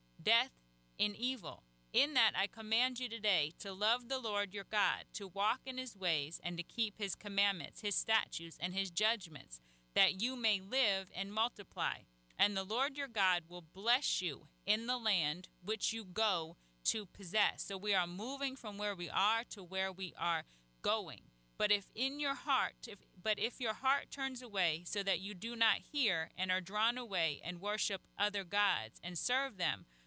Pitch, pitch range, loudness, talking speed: 205 Hz, 180-225 Hz, -36 LUFS, 190 wpm